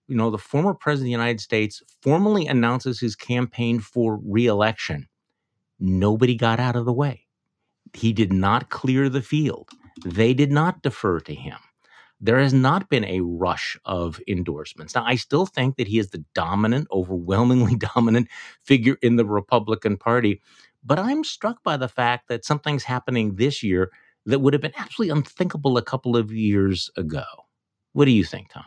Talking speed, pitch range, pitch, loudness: 175 wpm, 110-135 Hz, 120 Hz, -22 LUFS